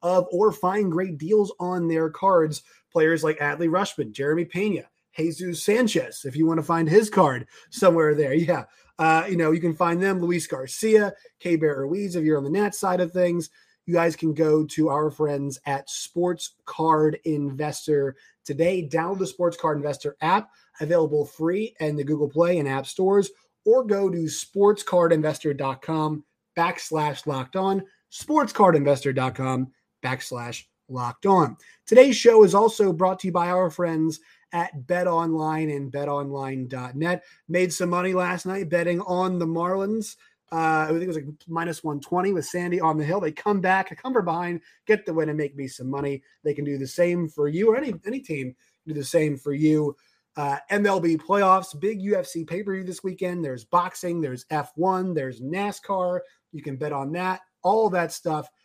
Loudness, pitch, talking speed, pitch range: -24 LUFS, 170 Hz, 180 wpm, 150-185 Hz